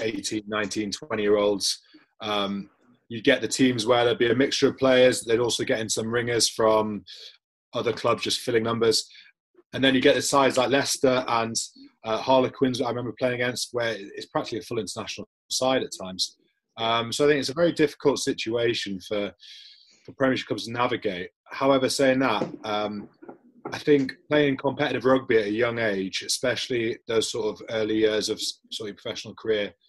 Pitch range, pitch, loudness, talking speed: 110-140 Hz, 125 Hz, -24 LUFS, 185 wpm